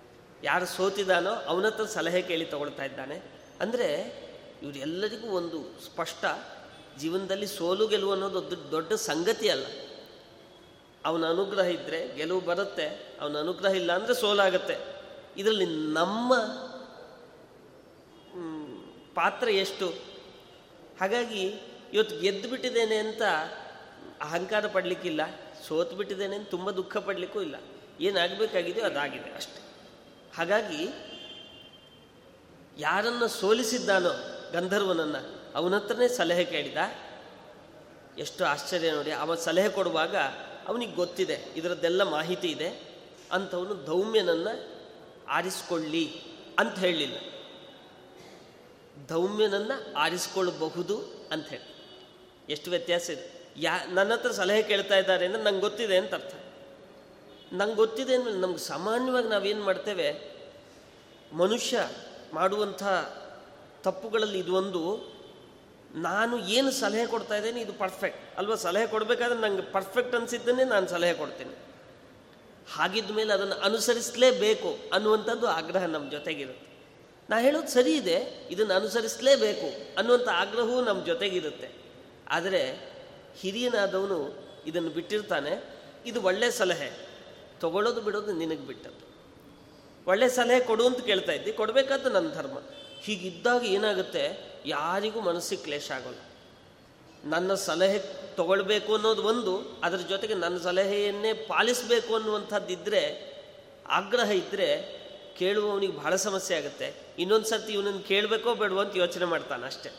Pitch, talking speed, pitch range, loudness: 200 Hz, 100 wpm, 180-225 Hz, -28 LUFS